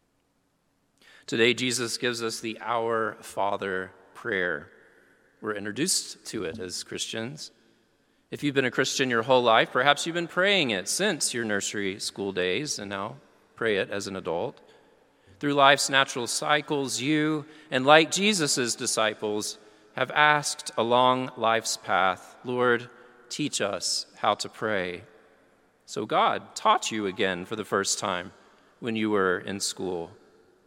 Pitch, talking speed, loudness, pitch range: 120 Hz, 145 wpm, -26 LUFS, 110-145 Hz